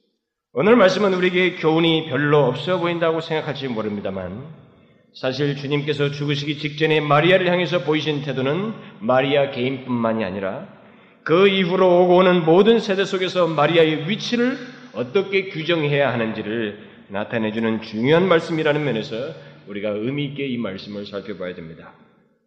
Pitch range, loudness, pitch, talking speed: 120-180 Hz, -19 LUFS, 150 Hz, 355 characters per minute